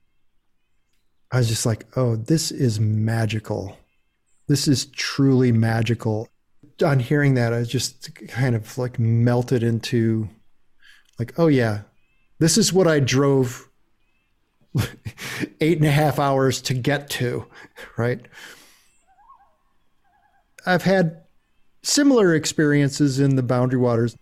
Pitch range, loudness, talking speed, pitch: 115-150 Hz, -21 LUFS, 115 wpm, 130 Hz